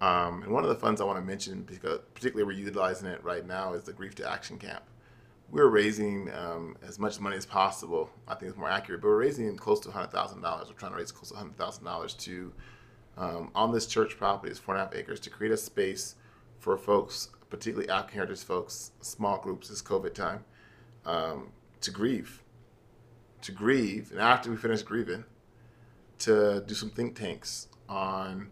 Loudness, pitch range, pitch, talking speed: -31 LUFS, 100-120 Hz, 115 Hz, 200 wpm